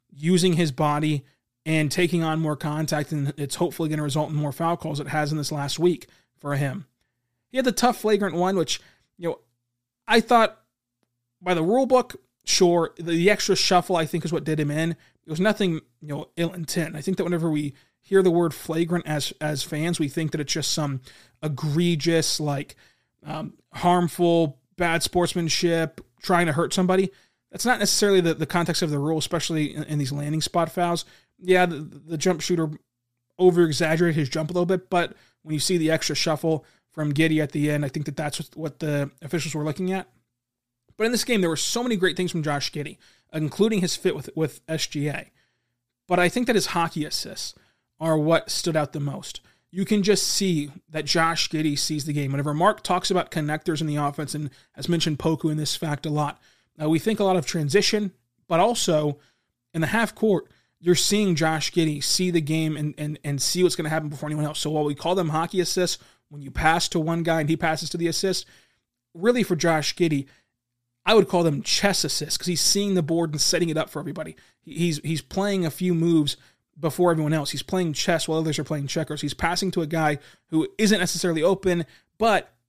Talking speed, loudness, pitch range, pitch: 215 wpm, -24 LUFS, 150-180 Hz, 160 Hz